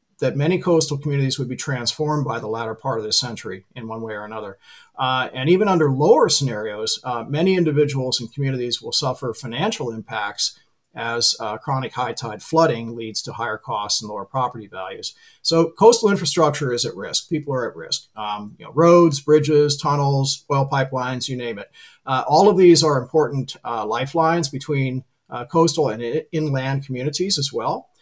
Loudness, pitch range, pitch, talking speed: -20 LUFS, 120-160 Hz, 135 Hz, 185 wpm